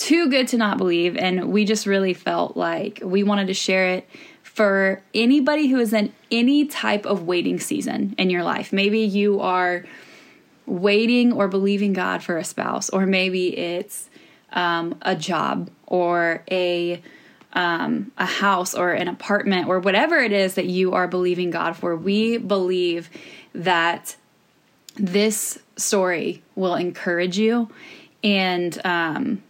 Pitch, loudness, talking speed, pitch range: 195 Hz, -21 LUFS, 150 wpm, 180-220 Hz